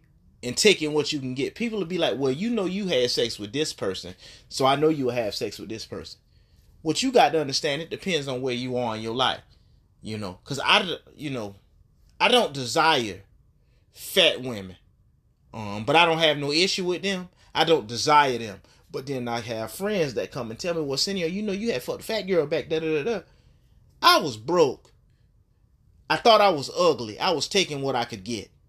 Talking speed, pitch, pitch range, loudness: 220 wpm, 135 Hz, 115-175 Hz, -24 LUFS